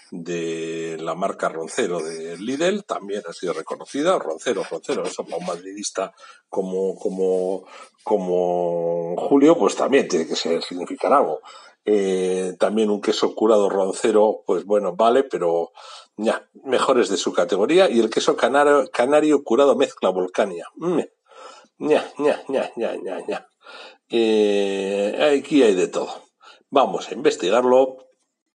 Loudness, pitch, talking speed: -21 LUFS, 105 Hz, 125 wpm